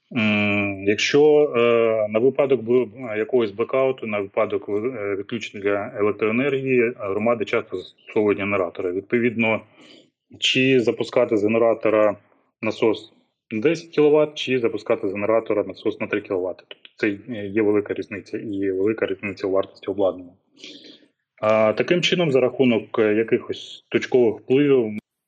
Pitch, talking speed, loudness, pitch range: 115 Hz, 120 wpm, -21 LUFS, 105-130 Hz